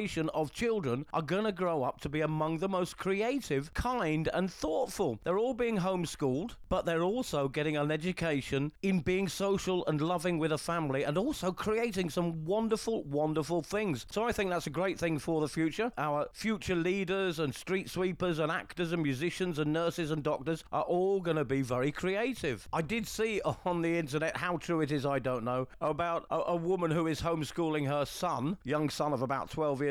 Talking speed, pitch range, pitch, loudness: 200 wpm, 150-185 Hz, 165 Hz, -33 LUFS